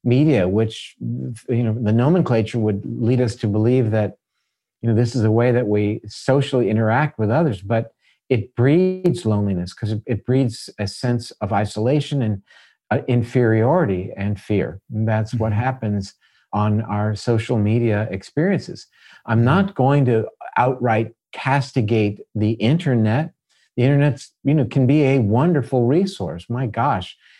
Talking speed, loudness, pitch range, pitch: 150 wpm, -20 LUFS, 105-130 Hz, 115 Hz